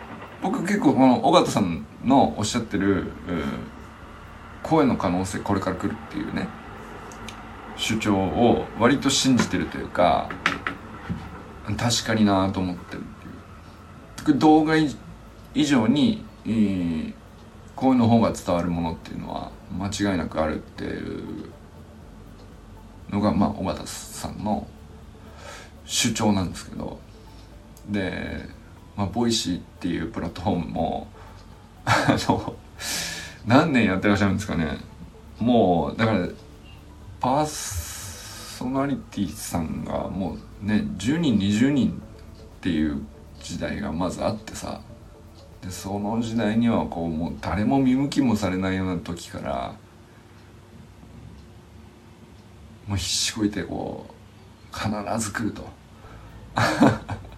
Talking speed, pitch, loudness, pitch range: 230 characters per minute, 100 Hz, -24 LUFS, 90-110 Hz